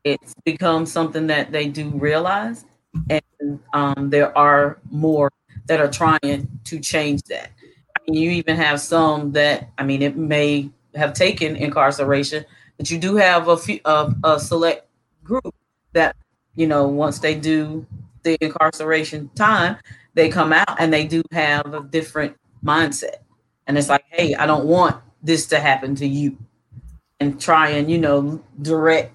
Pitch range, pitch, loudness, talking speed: 145-160 Hz, 150 Hz, -19 LUFS, 165 wpm